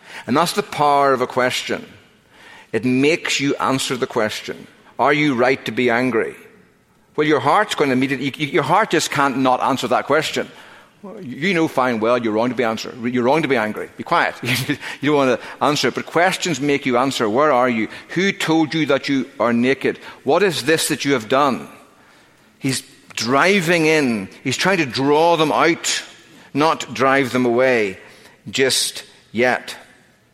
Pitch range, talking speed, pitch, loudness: 125-155 Hz, 180 wpm, 135 Hz, -18 LUFS